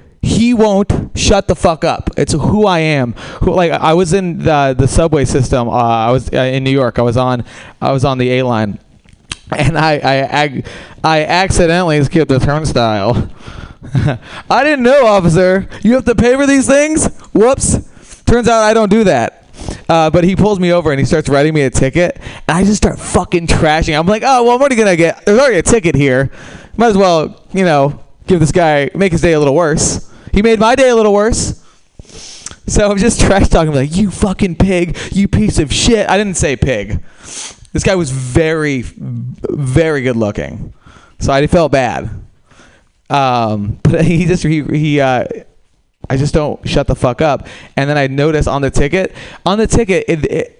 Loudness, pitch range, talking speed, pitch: -12 LUFS, 135-195 Hz, 205 wpm, 155 Hz